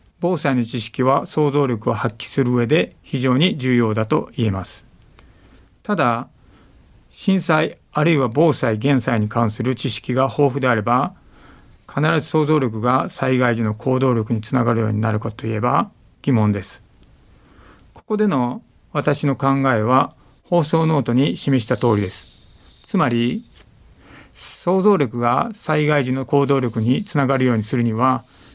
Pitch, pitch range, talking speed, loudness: 130 Hz, 115-145 Hz, 280 characters per minute, -19 LUFS